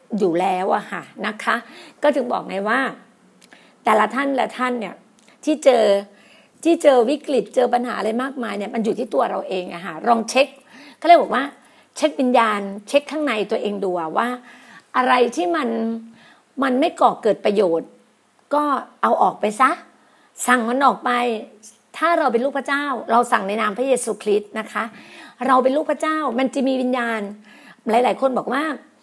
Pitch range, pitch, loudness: 225-280 Hz, 250 Hz, -20 LUFS